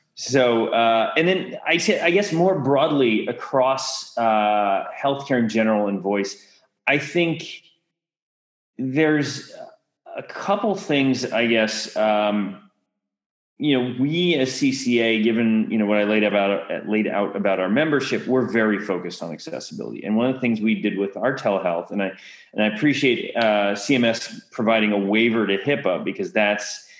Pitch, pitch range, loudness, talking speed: 115 Hz, 105-140 Hz, -21 LUFS, 160 wpm